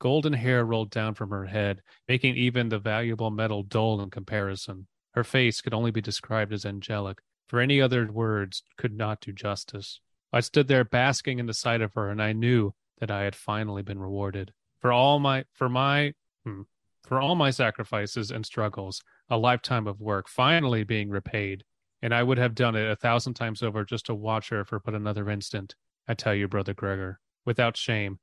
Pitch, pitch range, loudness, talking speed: 110 Hz, 100-120 Hz, -27 LUFS, 200 wpm